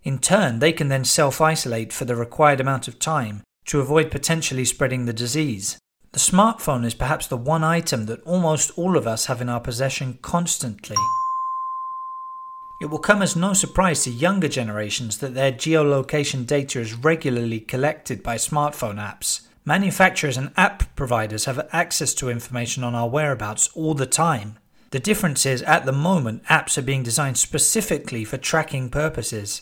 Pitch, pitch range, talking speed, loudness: 145 Hz, 125-160 Hz, 170 wpm, -21 LUFS